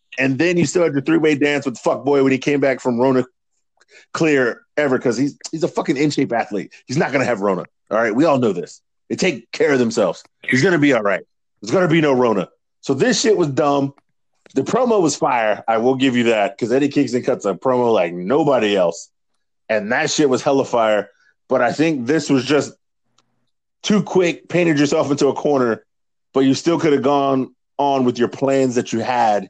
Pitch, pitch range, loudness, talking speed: 135 Hz, 125-150 Hz, -18 LUFS, 230 wpm